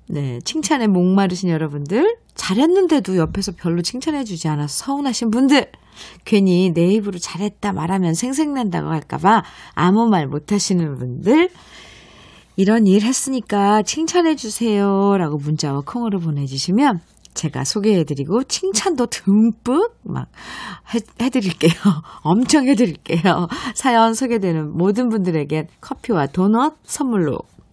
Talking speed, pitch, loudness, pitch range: 295 characters per minute, 200 Hz, -18 LUFS, 170-250 Hz